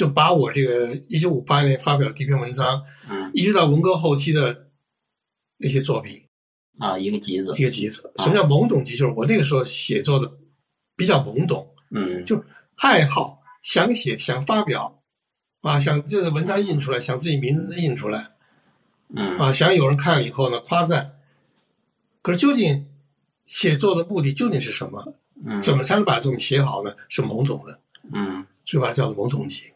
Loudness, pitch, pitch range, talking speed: -21 LUFS, 140 Hz, 125-165 Hz, 275 characters per minute